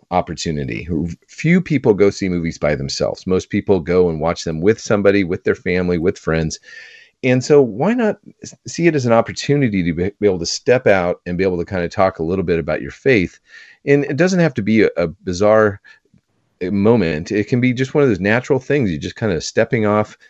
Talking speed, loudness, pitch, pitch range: 215 wpm, -17 LUFS, 105 Hz, 95-140 Hz